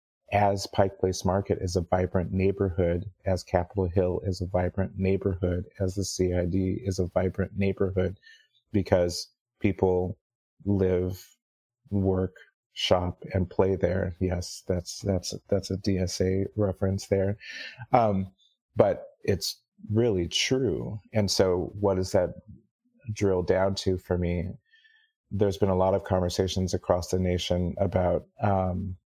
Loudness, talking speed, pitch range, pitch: -27 LUFS, 130 wpm, 90-100 Hz, 95 Hz